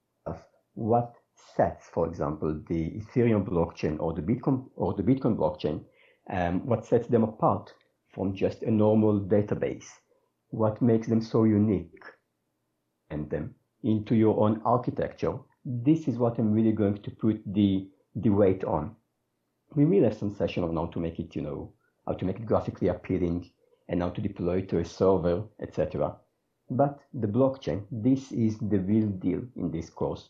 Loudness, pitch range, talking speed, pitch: -28 LUFS, 95-120 Hz, 170 wpm, 110 Hz